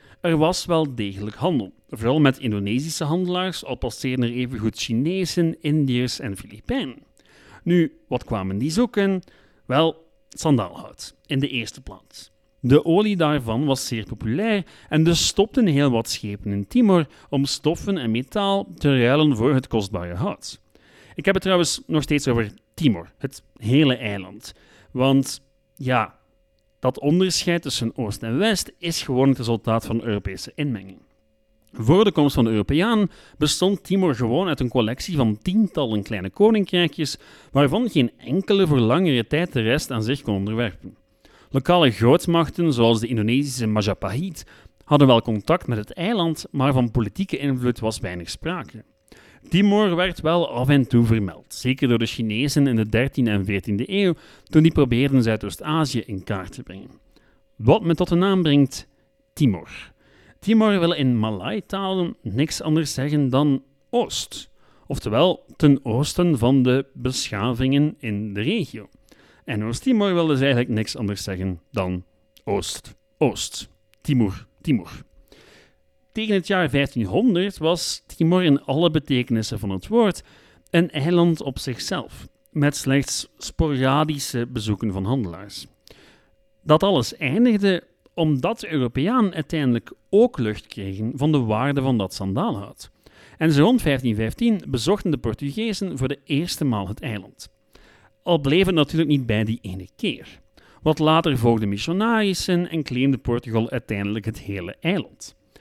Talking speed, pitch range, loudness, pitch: 150 wpm, 110-165 Hz, -22 LUFS, 135 Hz